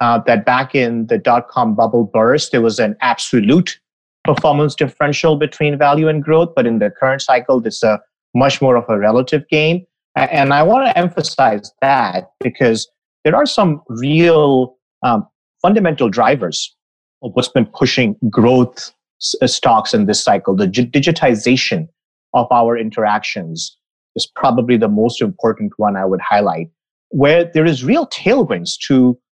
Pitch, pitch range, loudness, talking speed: 135 Hz, 120-160 Hz, -14 LUFS, 150 wpm